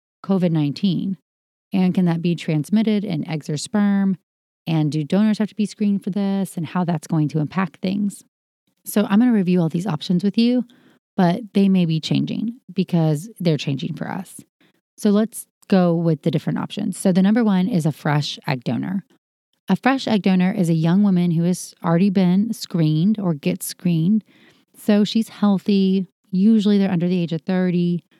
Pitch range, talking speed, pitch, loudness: 170-205 Hz, 190 wpm, 190 Hz, -20 LUFS